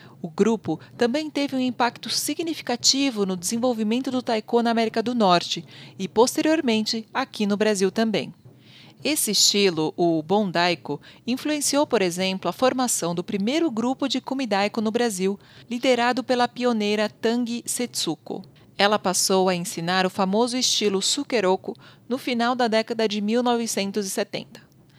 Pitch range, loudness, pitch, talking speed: 190-245 Hz, -23 LUFS, 225 Hz, 135 wpm